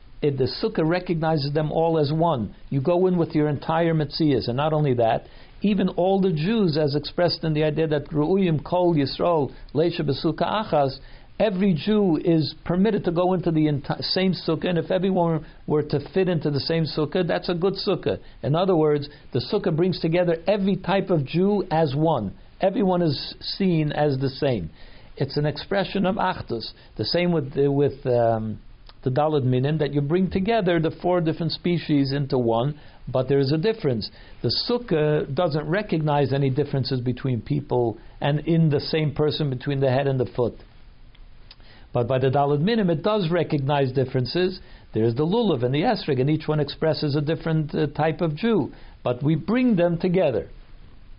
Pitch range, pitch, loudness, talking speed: 140-175 Hz, 155 Hz, -23 LUFS, 180 wpm